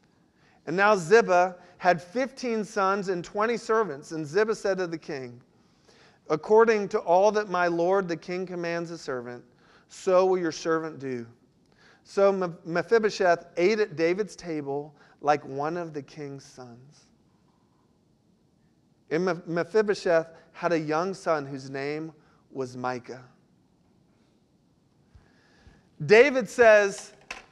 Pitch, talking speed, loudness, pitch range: 175 Hz, 120 wpm, -25 LUFS, 155-200 Hz